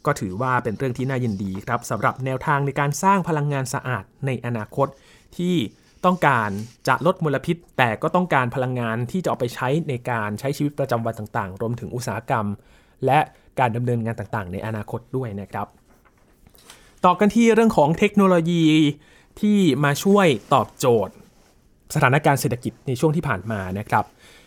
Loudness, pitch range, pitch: -22 LUFS, 115-155 Hz, 130 Hz